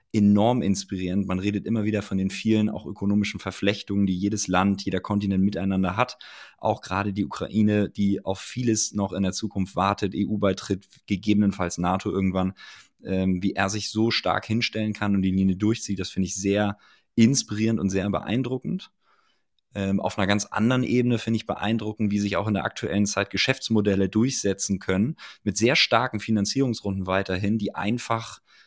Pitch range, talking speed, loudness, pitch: 95-110 Hz, 170 wpm, -25 LUFS, 100 Hz